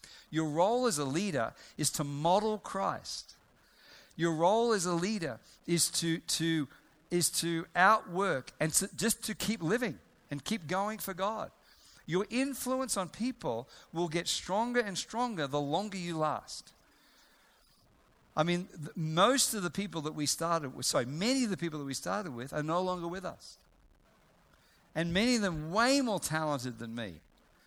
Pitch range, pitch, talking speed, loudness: 155-210 Hz, 175 Hz, 170 wpm, -32 LUFS